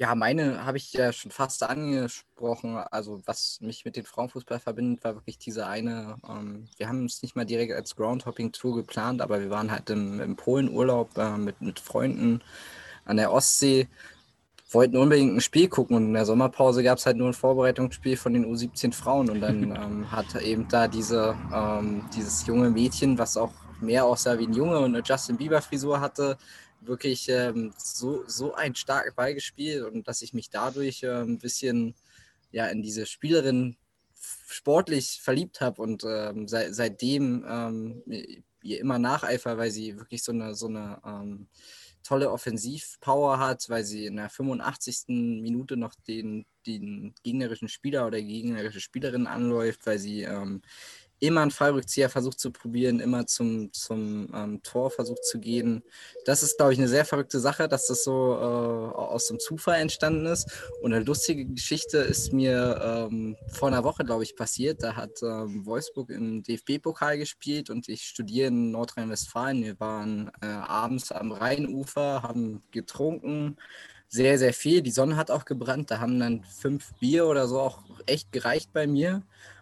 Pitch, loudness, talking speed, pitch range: 120 Hz, -27 LUFS, 175 wpm, 110-135 Hz